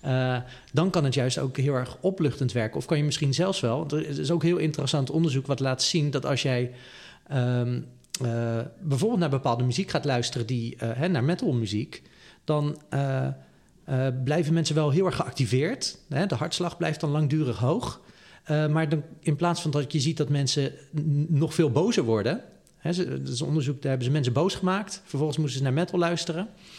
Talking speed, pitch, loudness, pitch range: 200 wpm, 145 Hz, -27 LUFS, 130-160 Hz